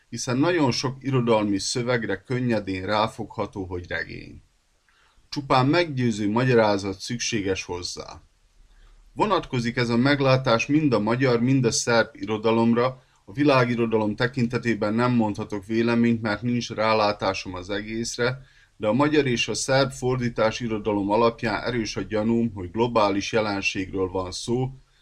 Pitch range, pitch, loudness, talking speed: 105-125 Hz, 115 Hz, -23 LUFS, 125 wpm